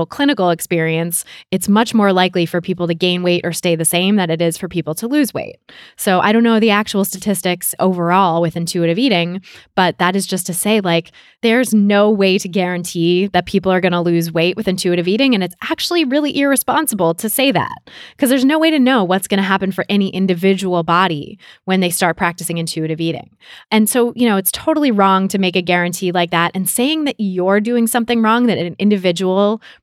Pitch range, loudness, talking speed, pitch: 175-220 Hz, -15 LUFS, 215 wpm, 190 Hz